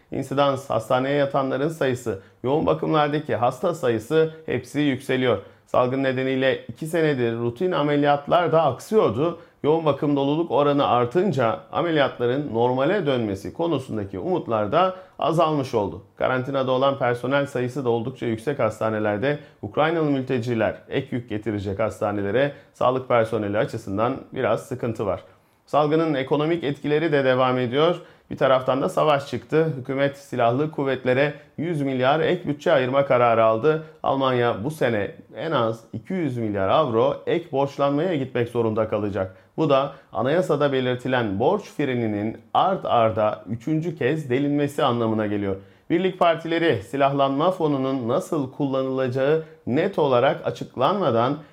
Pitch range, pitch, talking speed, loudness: 120-150 Hz, 135 Hz, 125 wpm, -23 LUFS